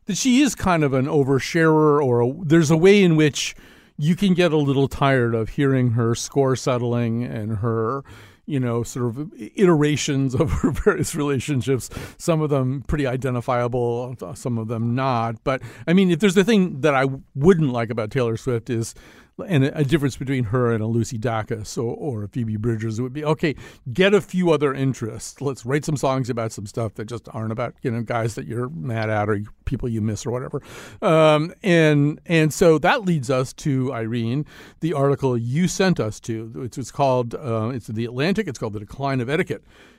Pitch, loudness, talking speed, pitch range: 135 Hz, -21 LUFS, 200 wpm, 115-155 Hz